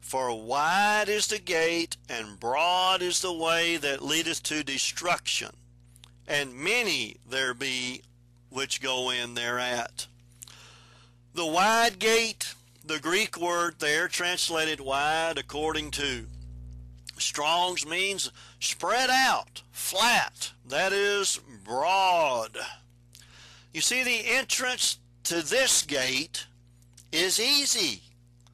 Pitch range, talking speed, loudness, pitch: 120-180 Hz, 105 wpm, -26 LUFS, 145 Hz